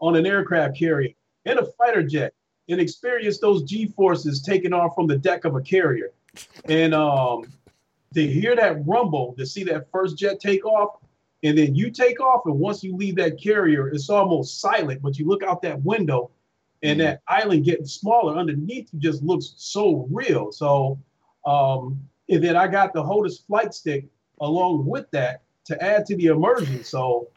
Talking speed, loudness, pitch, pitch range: 185 wpm, -22 LUFS, 165 Hz, 145-195 Hz